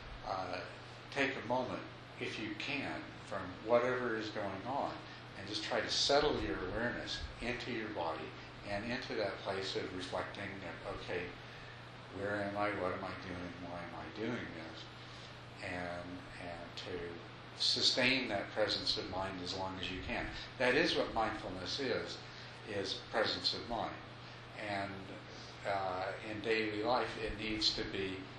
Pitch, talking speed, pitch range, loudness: 100 Hz, 155 wpm, 95-110 Hz, -38 LUFS